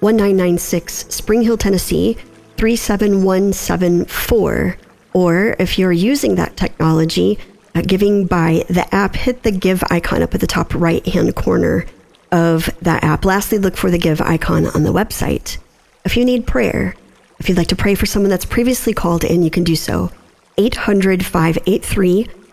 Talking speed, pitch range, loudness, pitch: 170 wpm, 175-210 Hz, -16 LUFS, 190 Hz